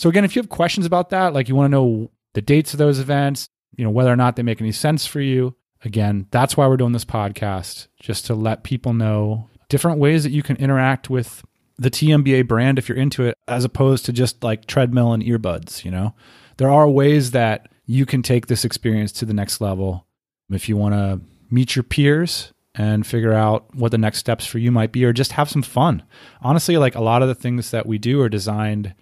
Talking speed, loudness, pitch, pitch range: 235 wpm, -19 LUFS, 125 Hz, 110-135 Hz